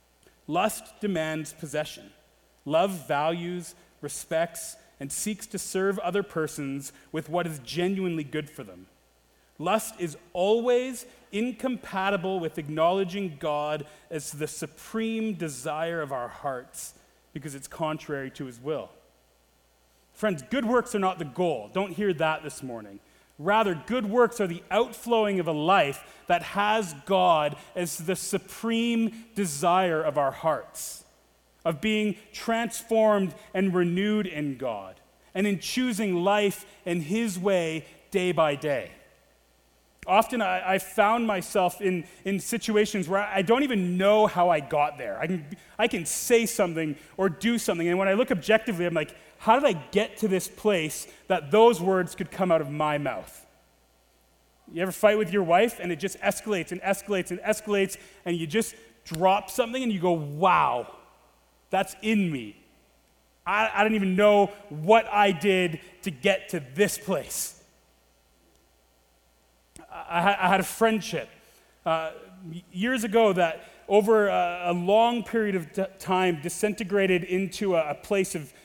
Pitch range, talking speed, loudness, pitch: 155-210 Hz, 150 wpm, -26 LUFS, 185 Hz